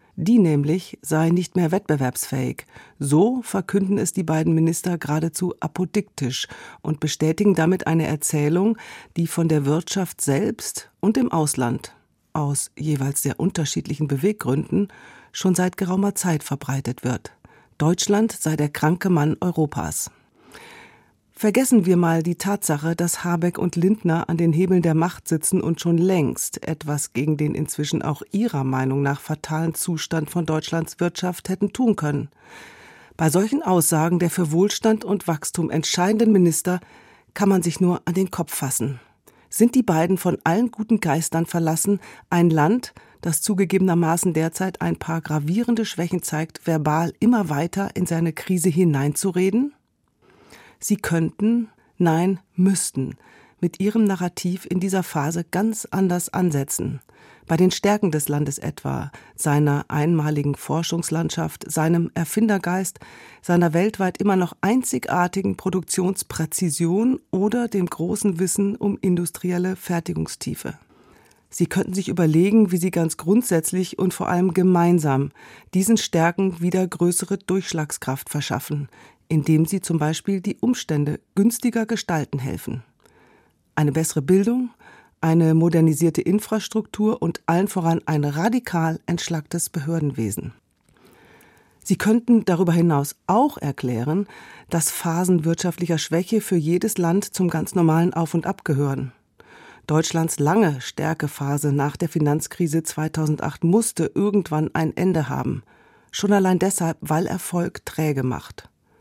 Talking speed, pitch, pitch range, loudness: 130 wpm, 170 Hz, 155-190 Hz, -22 LUFS